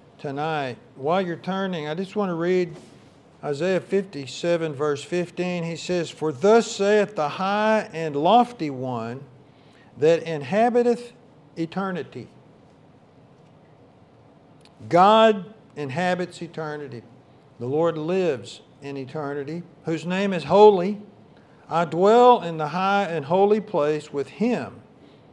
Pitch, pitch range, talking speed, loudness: 170 Hz, 150-195 Hz, 115 wpm, -22 LUFS